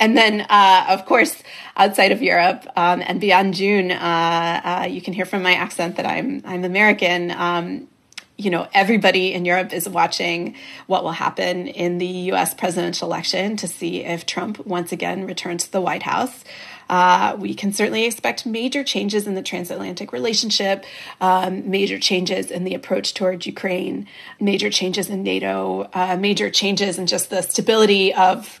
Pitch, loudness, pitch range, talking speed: 185 Hz, -19 LUFS, 180-205 Hz, 170 wpm